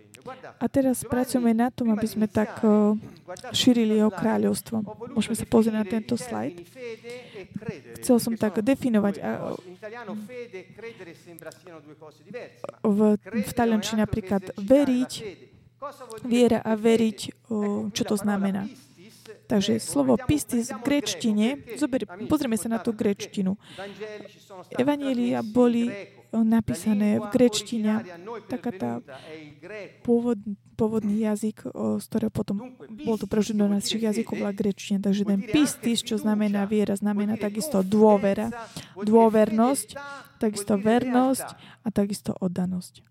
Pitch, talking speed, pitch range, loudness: 215 Hz, 105 wpm, 205-235 Hz, -25 LUFS